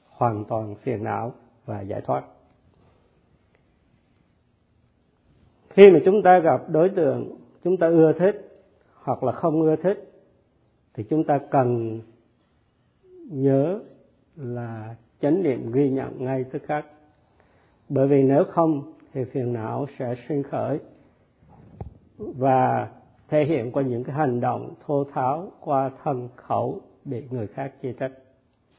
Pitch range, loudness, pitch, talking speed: 120-155 Hz, -23 LUFS, 135 Hz, 135 wpm